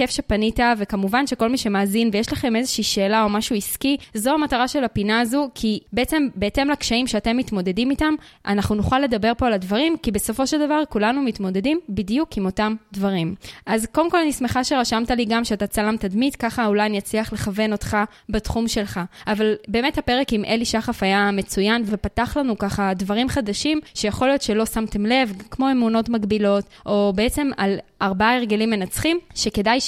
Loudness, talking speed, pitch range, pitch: -21 LUFS, 175 wpm, 210-255 Hz, 225 Hz